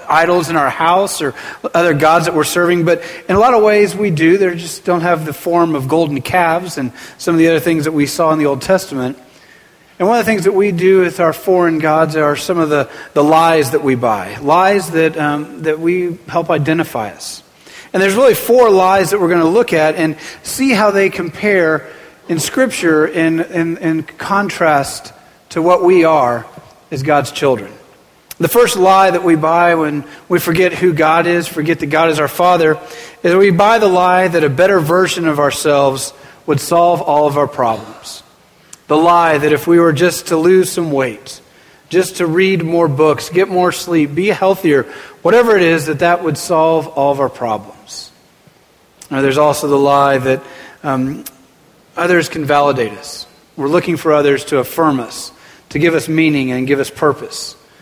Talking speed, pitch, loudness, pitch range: 200 wpm, 165 Hz, -13 LUFS, 150-180 Hz